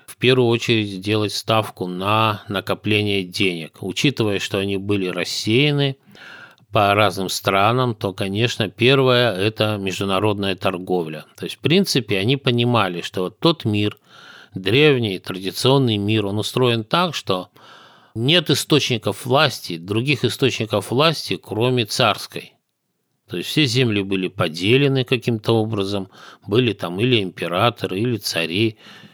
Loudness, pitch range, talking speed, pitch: -19 LUFS, 95-125 Hz, 125 wpm, 110 Hz